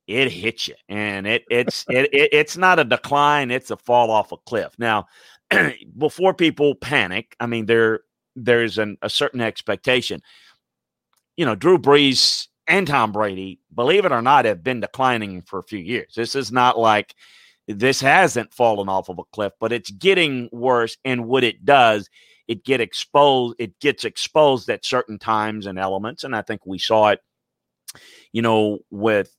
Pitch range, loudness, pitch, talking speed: 105-135 Hz, -19 LUFS, 120 Hz, 175 wpm